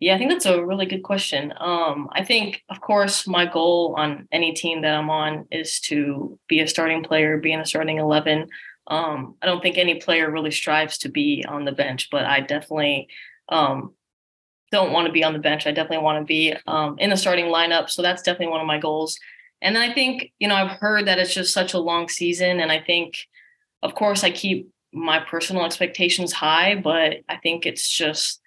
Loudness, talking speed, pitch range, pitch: -21 LUFS, 220 wpm, 155-185 Hz, 165 Hz